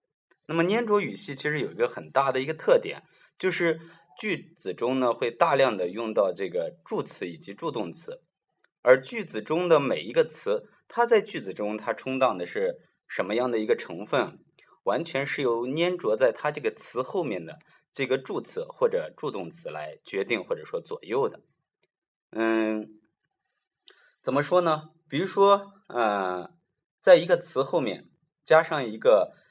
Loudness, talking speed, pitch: -27 LUFS, 240 characters per minute, 205 Hz